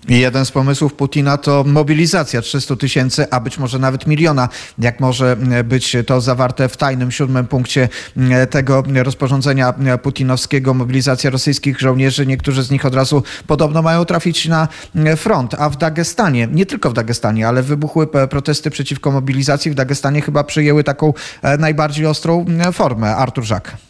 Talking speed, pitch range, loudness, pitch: 150 wpm, 130-150 Hz, -15 LUFS, 140 Hz